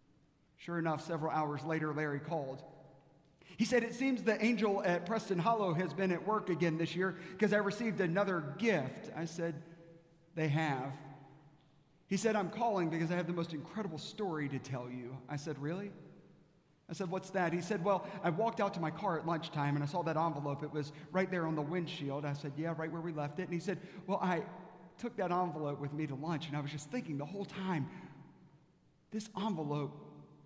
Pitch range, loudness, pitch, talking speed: 150-190 Hz, -37 LUFS, 165 Hz, 210 wpm